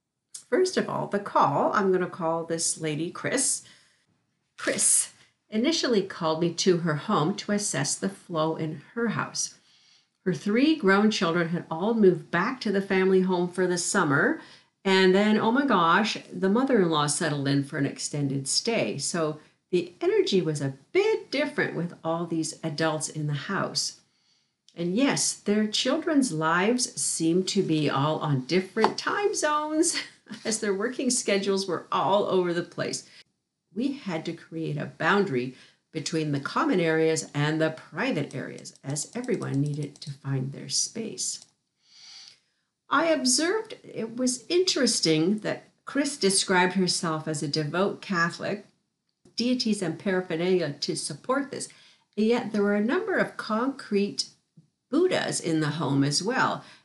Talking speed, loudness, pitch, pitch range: 155 wpm, -26 LUFS, 185 Hz, 160-225 Hz